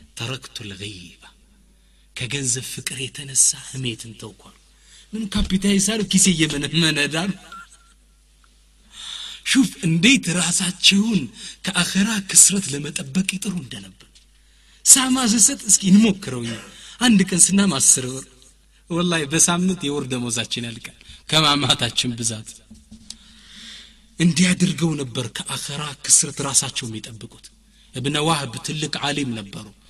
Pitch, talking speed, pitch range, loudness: 155 Hz, 100 wpm, 130-190 Hz, -18 LUFS